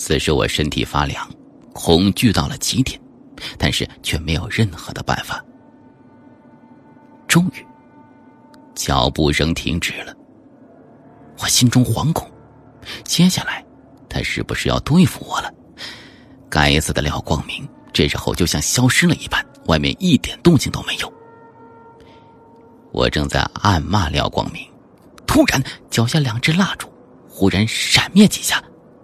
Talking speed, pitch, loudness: 195 characters per minute, 105 Hz, -18 LUFS